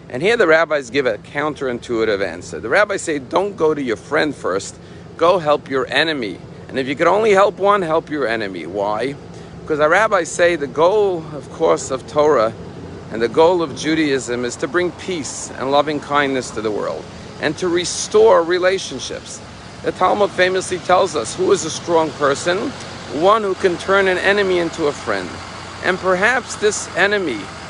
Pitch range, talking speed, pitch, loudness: 140-185 Hz, 180 wpm, 160 Hz, -17 LUFS